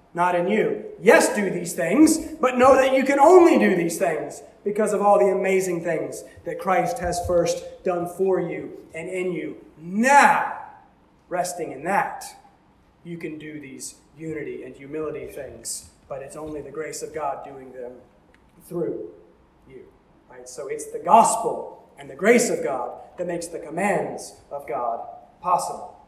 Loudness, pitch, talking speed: -21 LUFS, 185 Hz, 165 wpm